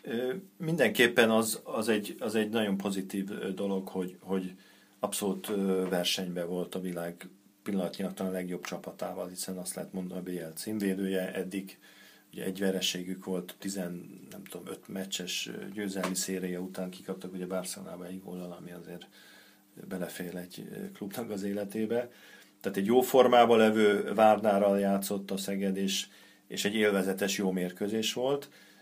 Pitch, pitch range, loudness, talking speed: 95 Hz, 90-105 Hz, -31 LUFS, 145 wpm